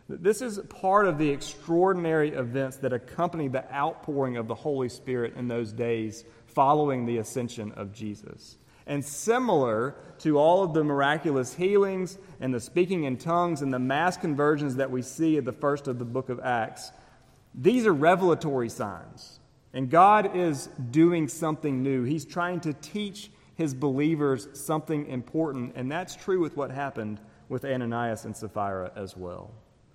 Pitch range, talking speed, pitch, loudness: 125-165 Hz, 160 wpm, 140 Hz, -27 LUFS